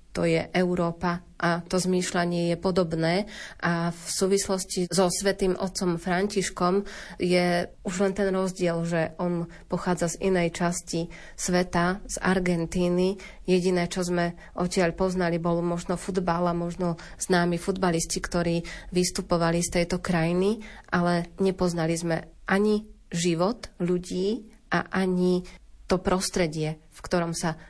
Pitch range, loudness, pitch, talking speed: 170-190 Hz, -26 LUFS, 180 Hz, 130 wpm